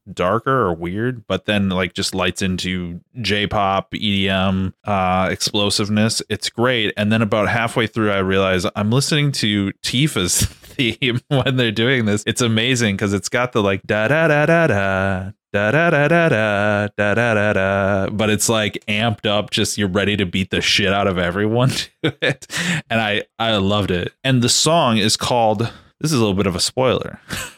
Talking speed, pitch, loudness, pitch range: 185 wpm, 105 Hz, -18 LUFS, 95-115 Hz